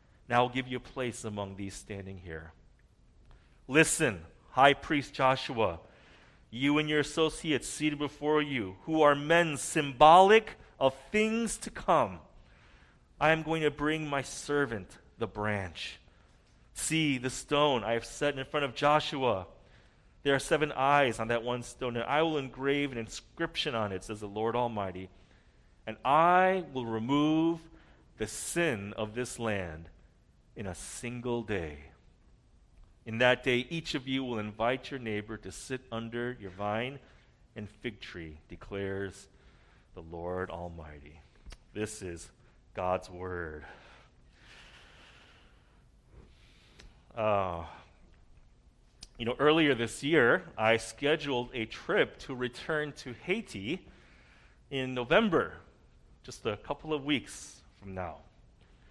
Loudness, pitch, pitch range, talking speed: -30 LUFS, 120 Hz, 95-145 Hz, 130 wpm